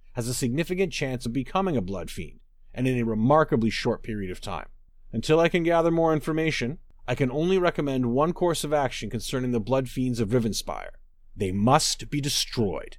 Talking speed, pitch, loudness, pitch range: 190 wpm, 130 Hz, -25 LUFS, 115-155 Hz